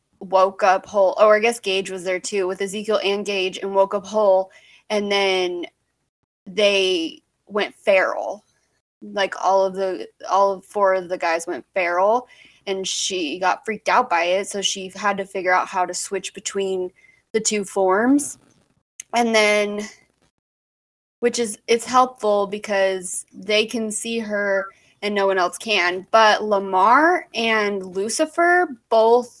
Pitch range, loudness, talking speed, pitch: 190-220 Hz, -20 LUFS, 155 wpm, 200 Hz